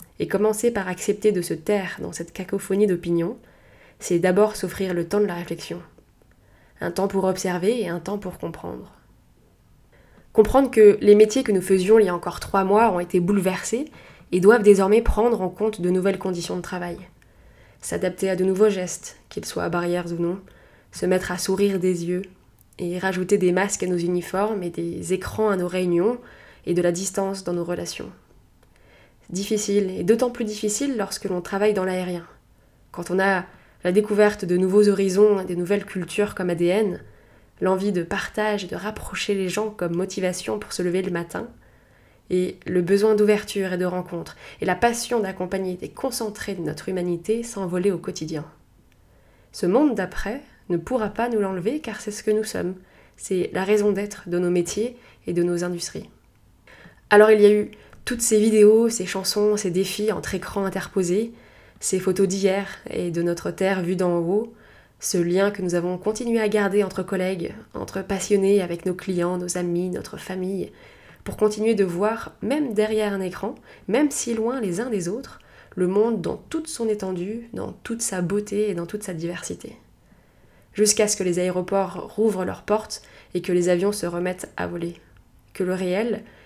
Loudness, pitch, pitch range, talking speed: -23 LUFS, 195 Hz, 180-210 Hz, 185 wpm